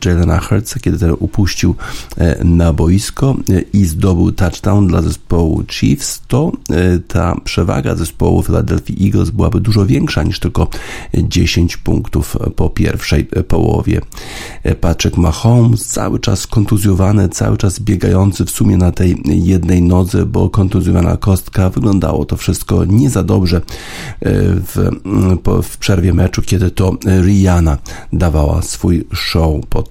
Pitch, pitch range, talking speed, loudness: 95 Hz, 85-105 Hz, 125 wpm, -13 LUFS